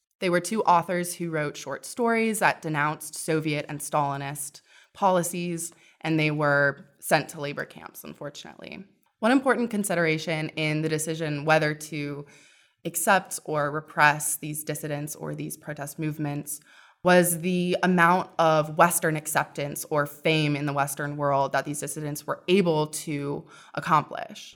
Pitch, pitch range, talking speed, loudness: 155 Hz, 150-175 Hz, 140 wpm, -25 LUFS